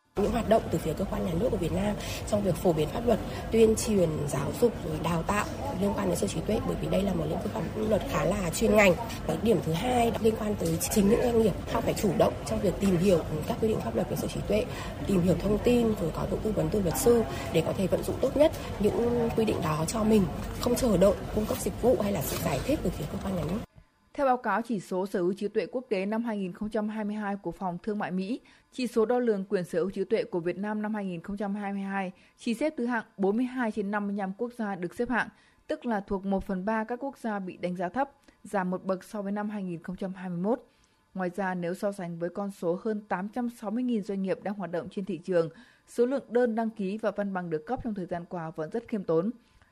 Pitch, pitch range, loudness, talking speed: 205 Hz, 185-230 Hz, -29 LUFS, 255 wpm